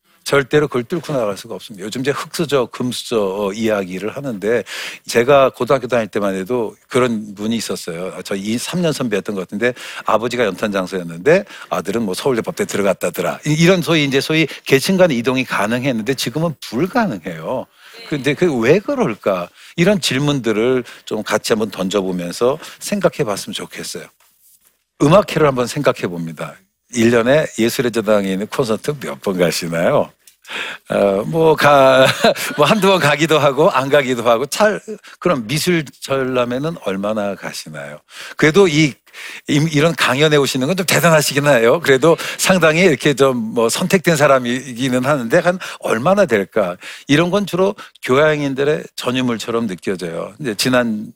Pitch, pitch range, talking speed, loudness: 135 Hz, 115-160 Hz, 330 characters per minute, -16 LUFS